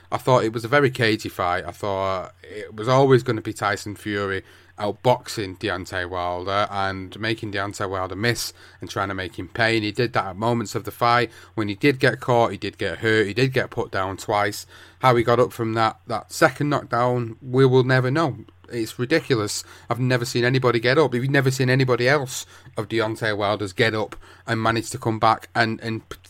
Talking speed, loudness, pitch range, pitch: 215 wpm, -22 LUFS, 100-125 Hz, 110 Hz